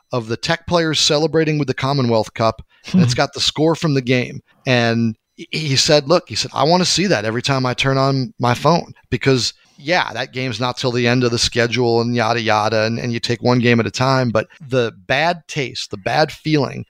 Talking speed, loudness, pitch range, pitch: 230 wpm, -17 LUFS, 120-150 Hz, 130 Hz